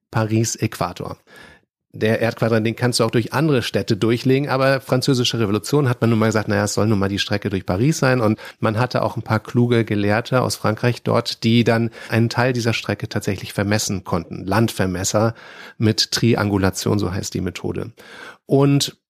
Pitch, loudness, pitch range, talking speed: 115 Hz, -19 LUFS, 105-120 Hz, 180 wpm